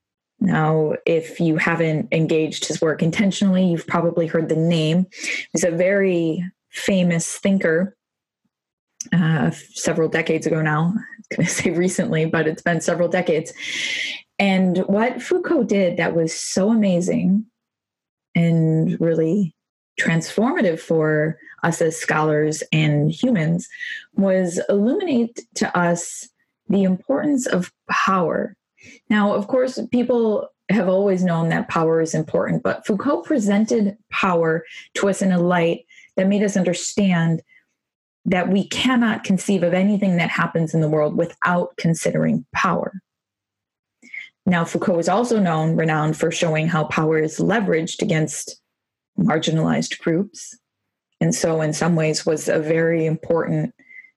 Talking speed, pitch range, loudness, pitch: 130 wpm, 165-205 Hz, -20 LUFS, 175 Hz